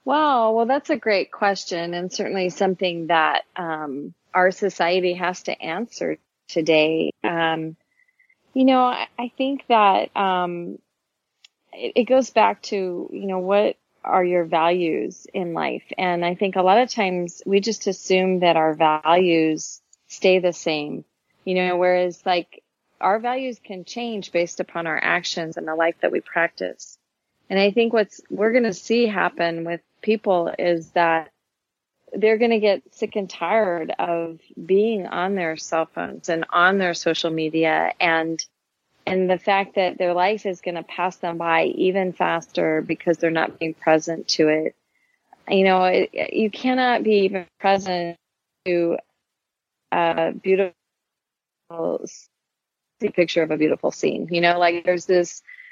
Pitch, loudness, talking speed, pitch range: 180 Hz, -21 LUFS, 155 wpm, 170-205 Hz